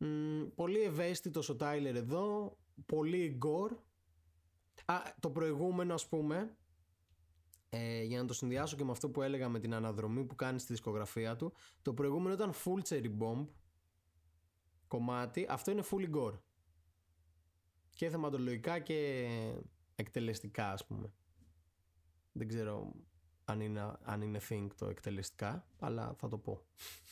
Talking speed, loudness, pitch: 135 wpm, -40 LUFS, 115 Hz